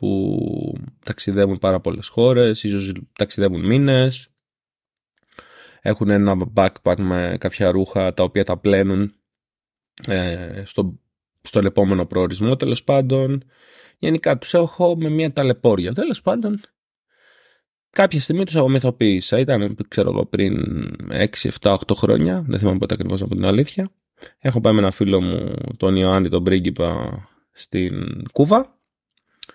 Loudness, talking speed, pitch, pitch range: -19 LUFS, 125 wpm, 105 Hz, 95-135 Hz